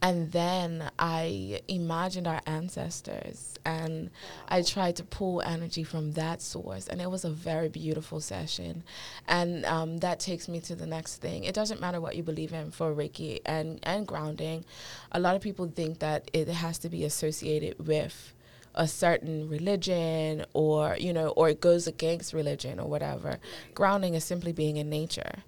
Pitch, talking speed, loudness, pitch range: 160 Hz, 175 wpm, -31 LUFS, 155-175 Hz